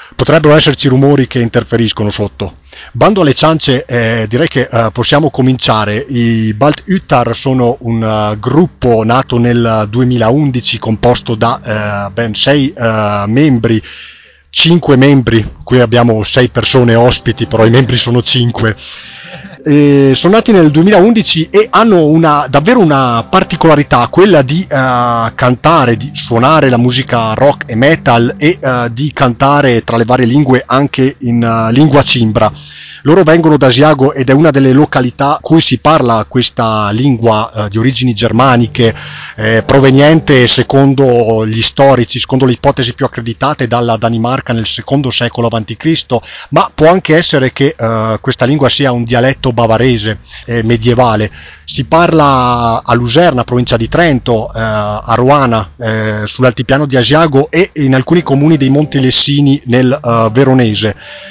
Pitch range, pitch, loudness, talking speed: 115-140 Hz, 125 Hz, -9 LUFS, 150 wpm